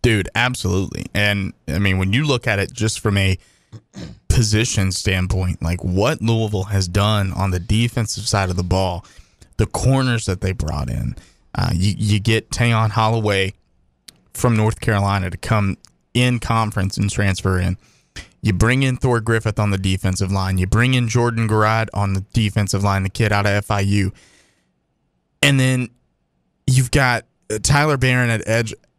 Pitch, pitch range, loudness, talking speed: 105 Hz, 95-115 Hz, -19 LUFS, 165 wpm